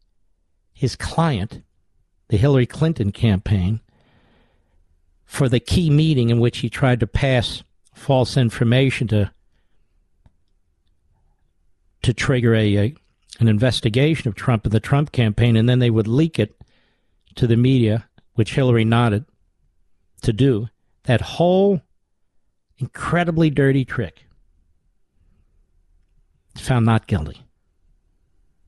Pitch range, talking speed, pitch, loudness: 85-125 Hz, 110 wpm, 110 Hz, -19 LUFS